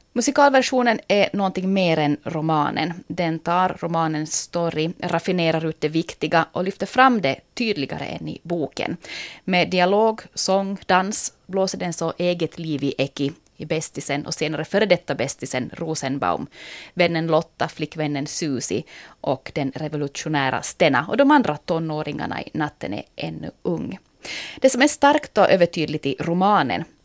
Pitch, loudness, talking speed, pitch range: 165 Hz, -21 LUFS, 145 wpm, 150-190 Hz